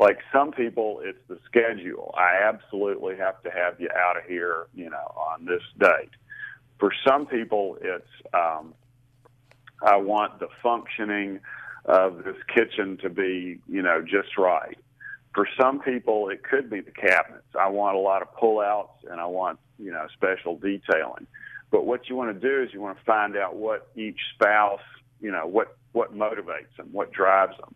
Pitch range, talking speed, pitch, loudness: 95-120 Hz, 180 wpm, 100 Hz, -25 LUFS